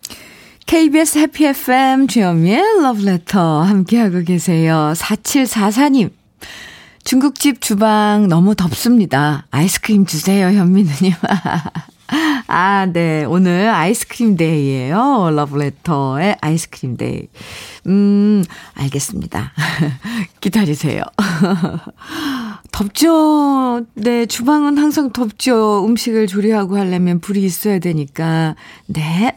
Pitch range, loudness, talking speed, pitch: 170-240 Hz, -15 LUFS, 225 characters per minute, 200 Hz